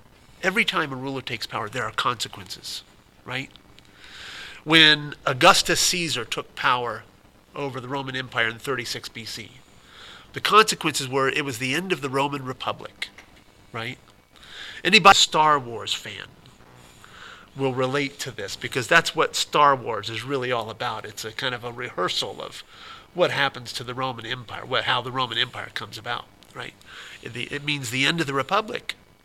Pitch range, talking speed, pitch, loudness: 120-145 Hz, 165 wpm, 135 Hz, -22 LUFS